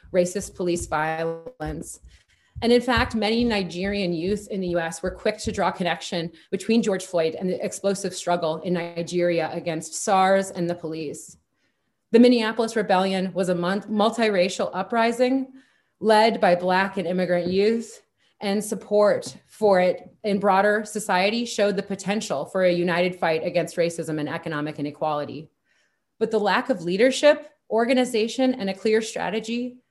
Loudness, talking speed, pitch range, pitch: -23 LUFS, 145 wpm, 175-220 Hz, 195 Hz